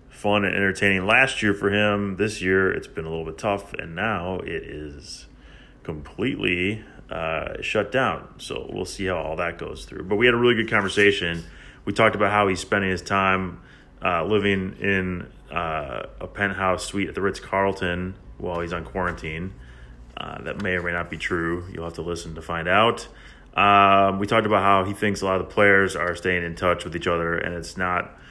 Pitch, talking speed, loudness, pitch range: 95 Hz, 210 wpm, -23 LUFS, 85-100 Hz